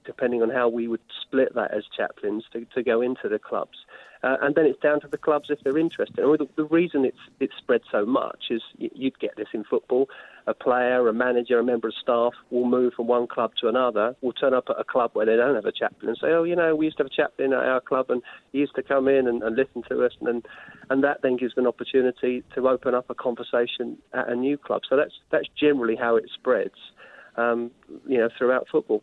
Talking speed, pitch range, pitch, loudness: 255 wpm, 120-140 Hz, 125 Hz, -24 LUFS